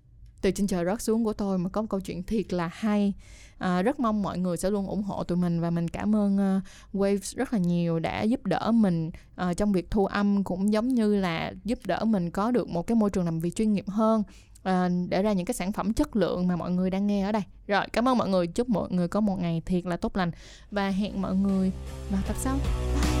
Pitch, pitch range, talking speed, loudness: 195 Hz, 180-210 Hz, 260 wpm, -27 LUFS